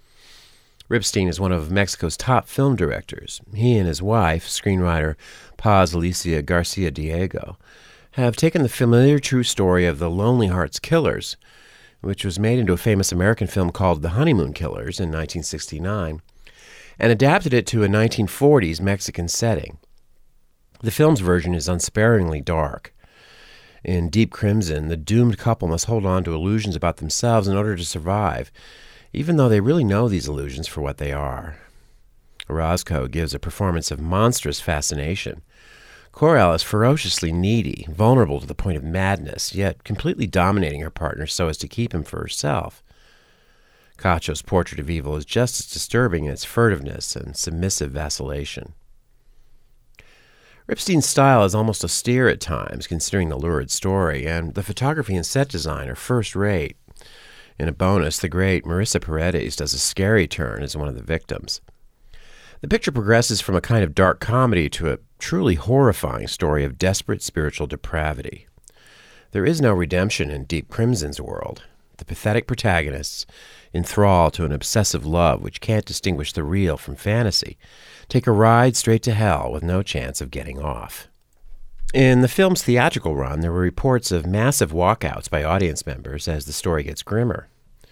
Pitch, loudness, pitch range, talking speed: 90 Hz, -21 LUFS, 80-110 Hz, 160 wpm